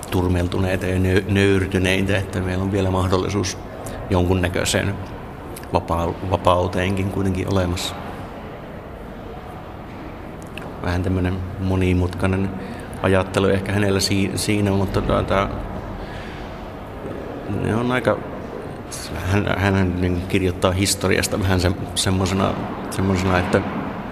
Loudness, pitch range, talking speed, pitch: -21 LUFS, 90-100 Hz, 80 wpm, 95 Hz